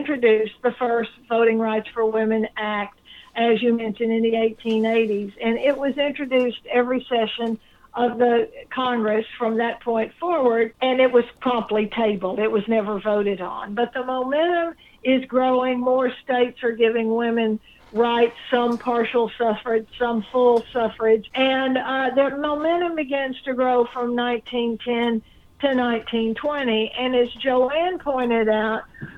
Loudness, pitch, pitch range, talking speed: -22 LUFS, 235 Hz, 225-255 Hz, 145 wpm